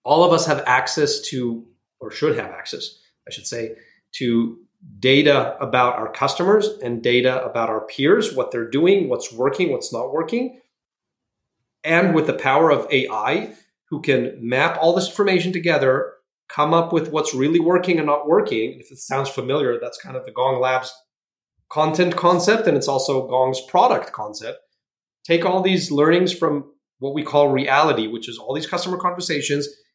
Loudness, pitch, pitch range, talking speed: -19 LUFS, 145 Hz, 130-175 Hz, 170 wpm